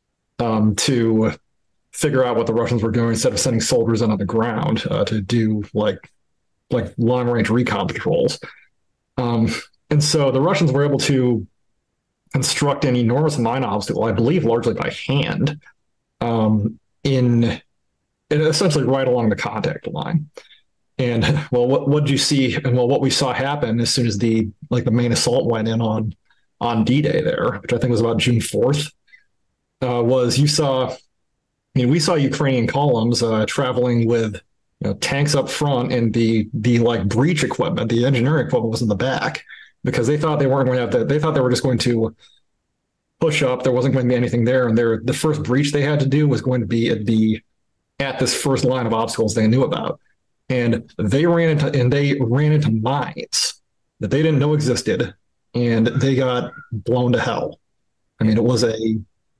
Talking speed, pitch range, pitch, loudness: 195 wpm, 115-140 Hz, 125 Hz, -19 LUFS